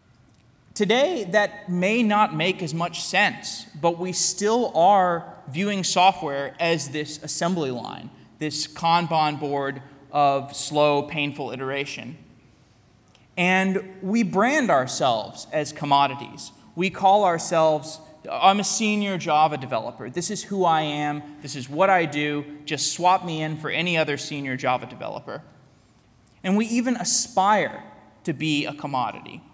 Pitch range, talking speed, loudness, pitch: 140-190 Hz, 135 wpm, -23 LUFS, 155 Hz